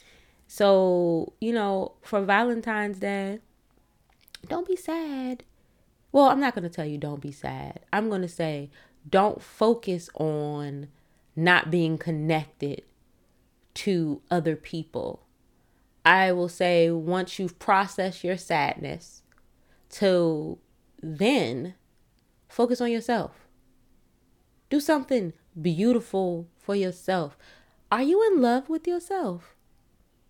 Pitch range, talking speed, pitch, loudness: 160-225 Hz, 105 wpm, 185 Hz, -26 LUFS